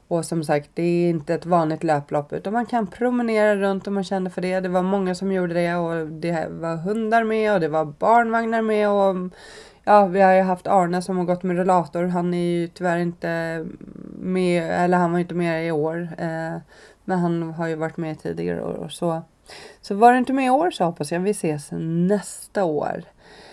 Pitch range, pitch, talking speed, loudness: 165-200 Hz, 175 Hz, 220 wpm, -22 LUFS